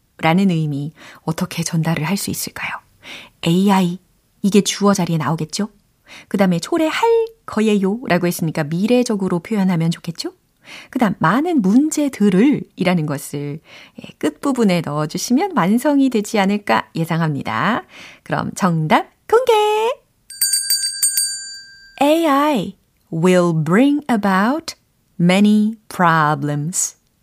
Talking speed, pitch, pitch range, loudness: 280 characters per minute, 200 Hz, 170-275 Hz, -17 LUFS